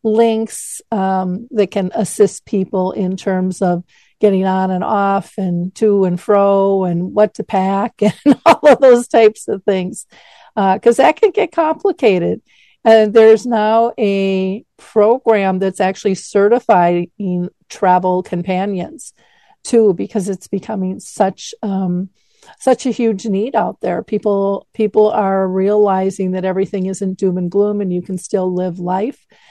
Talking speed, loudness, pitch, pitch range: 145 wpm, -15 LUFS, 200 Hz, 190-220 Hz